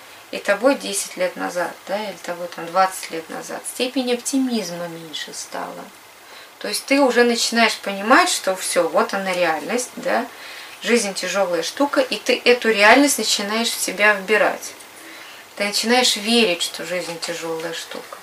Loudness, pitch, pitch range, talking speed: -19 LUFS, 215 Hz, 190-245 Hz, 150 wpm